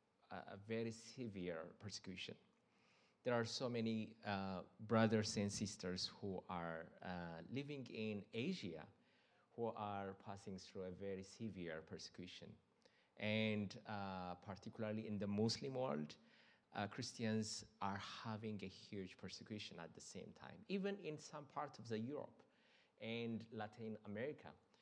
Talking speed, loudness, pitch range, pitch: 130 wpm, -47 LUFS, 95-115 Hz, 105 Hz